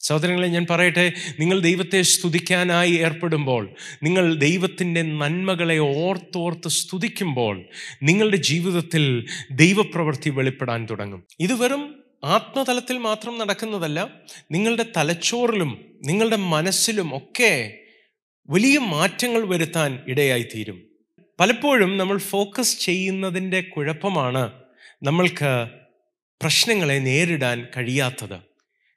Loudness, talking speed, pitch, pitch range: -21 LUFS, 85 wpm, 170 Hz, 145-195 Hz